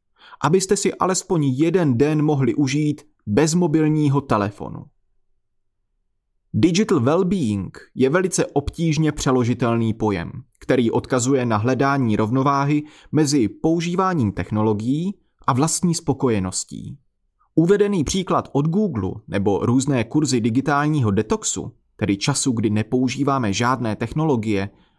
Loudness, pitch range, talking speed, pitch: -20 LUFS, 110-155 Hz, 105 wpm, 135 Hz